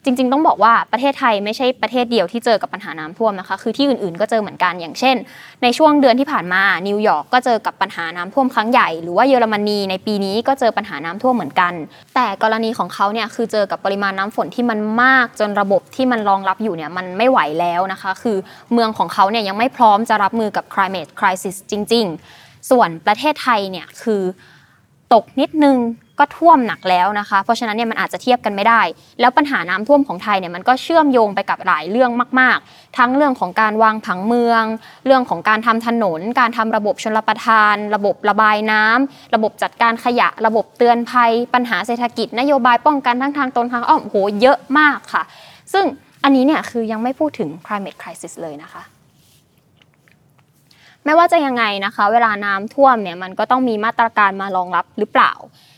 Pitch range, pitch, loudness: 195-250 Hz, 220 Hz, -16 LUFS